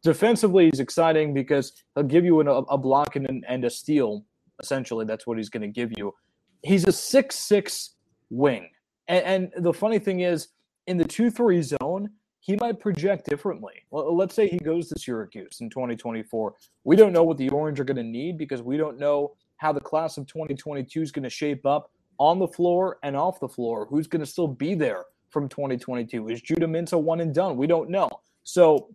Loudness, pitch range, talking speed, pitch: -24 LUFS, 135-180 Hz, 205 wpm, 155 Hz